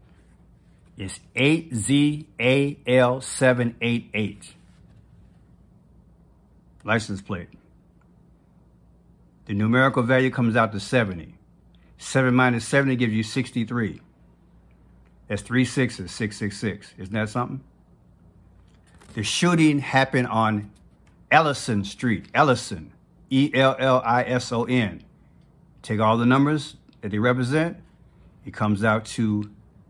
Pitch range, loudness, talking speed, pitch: 100-130 Hz, -22 LUFS, 100 wpm, 115 Hz